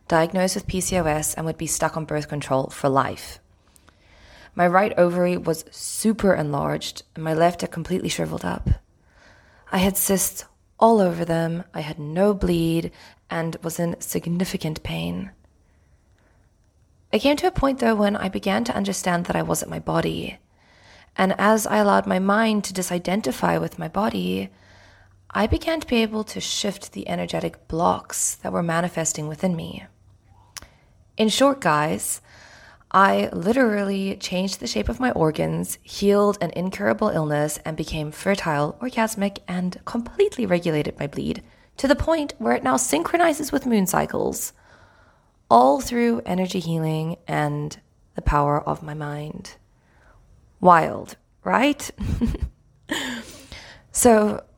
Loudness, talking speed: -22 LUFS, 140 wpm